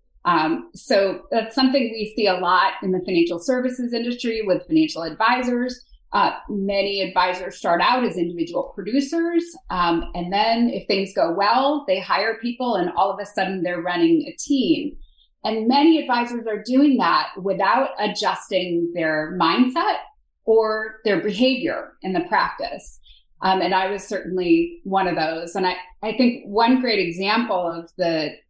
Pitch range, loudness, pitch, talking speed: 180-250 Hz, -21 LUFS, 205 Hz, 160 wpm